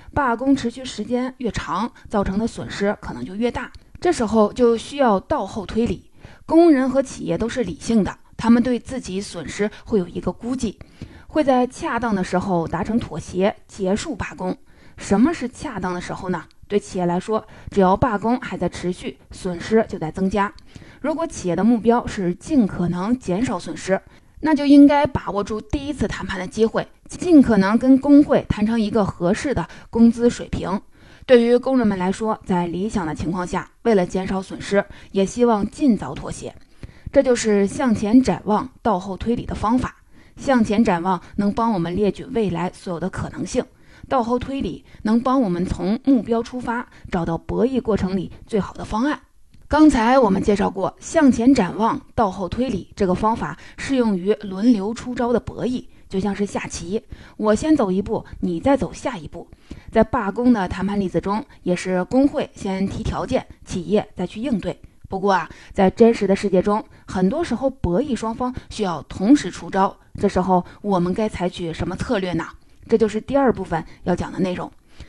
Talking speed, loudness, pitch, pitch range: 275 characters per minute, -21 LUFS, 215 Hz, 185-245 Hz